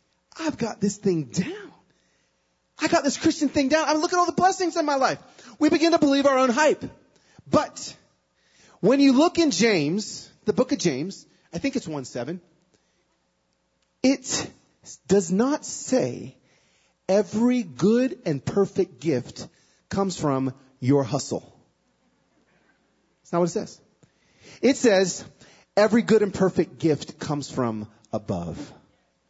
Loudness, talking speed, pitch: -23 LUFS, 145 wpm, 200 Hz